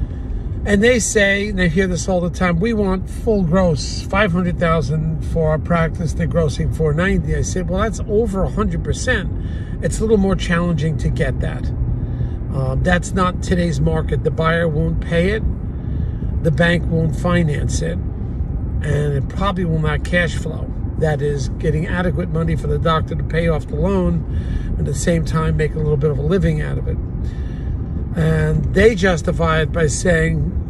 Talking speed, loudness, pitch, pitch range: 185 wpm, -18 LUFS, 160 Hz, 140-175 Hz